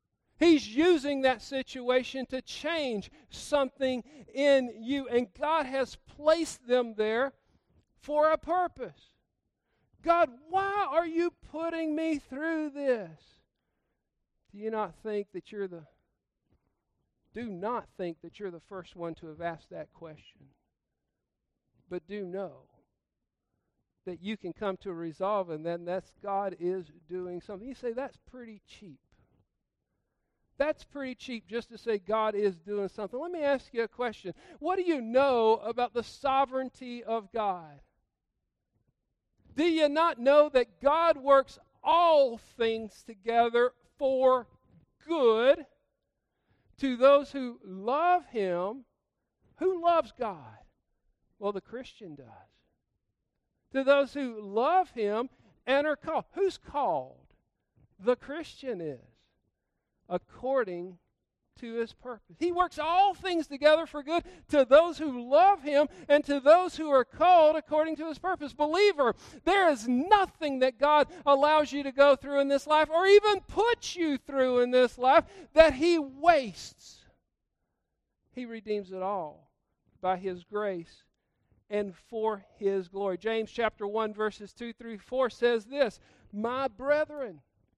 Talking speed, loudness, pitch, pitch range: 140 wpm, -28 LUFS, 255 Hz, 205-300 Hz